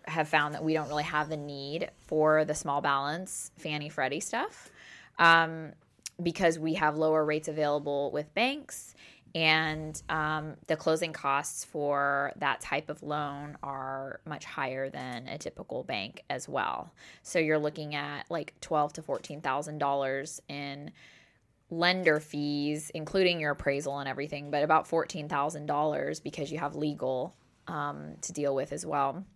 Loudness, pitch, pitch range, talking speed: -31 LUFS, 150 Hz, 140-155 Hz, 155 wpm